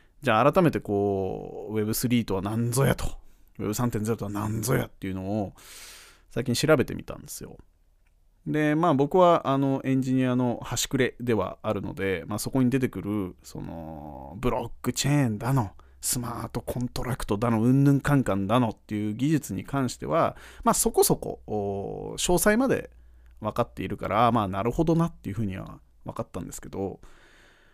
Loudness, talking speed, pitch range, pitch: -26 LUFS, 345 characters per minute, 100-135 Hz, 115 Hz